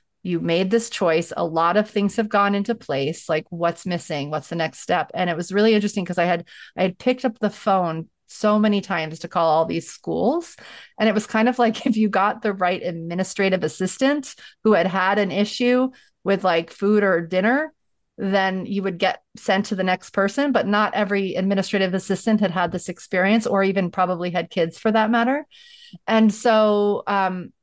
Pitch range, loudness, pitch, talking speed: 180-215 Hz, -21 LUFS, 195 Hz, 200 wpm